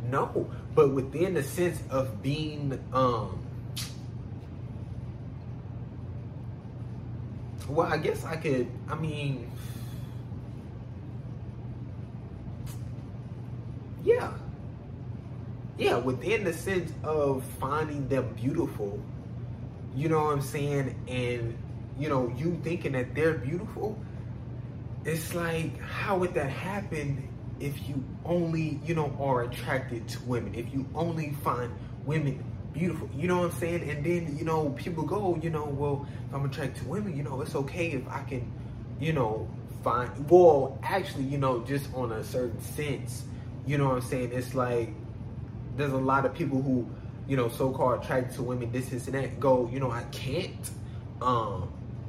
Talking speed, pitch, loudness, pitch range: 145 wpm, 125 Hz, -31 LUFS, 120-140 Hz